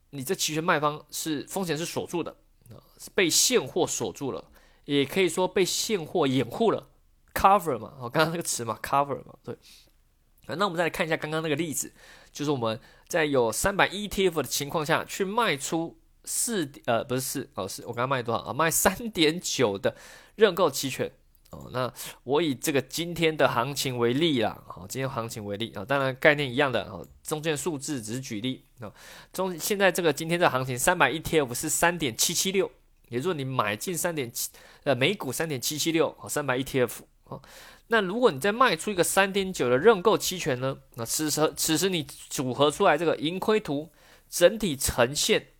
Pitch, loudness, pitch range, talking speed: 150 Hz, -26 LUFS, 130-175 Hz, 305 characters per minute